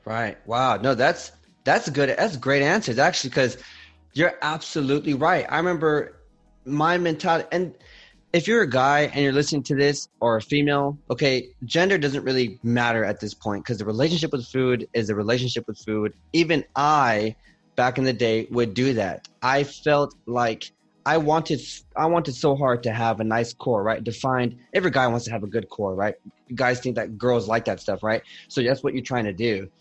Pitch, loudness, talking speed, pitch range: 130 Hz, -23 LUFS, 200 wpm, 115-145 Hz